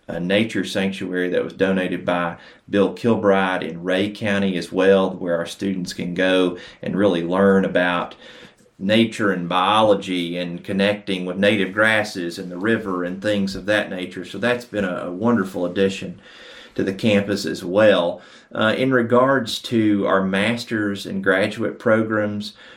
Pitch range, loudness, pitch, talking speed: 90-105 Hz, -20 LUFS, 95 Hz, 155 wpm